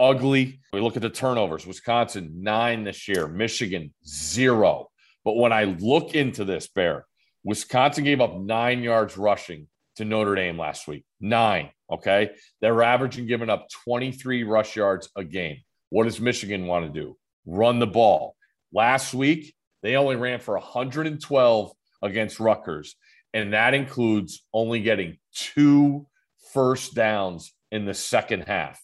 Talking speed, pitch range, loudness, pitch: 150 wpm, 105-130 Hz, -23 LUFS, 115 Hz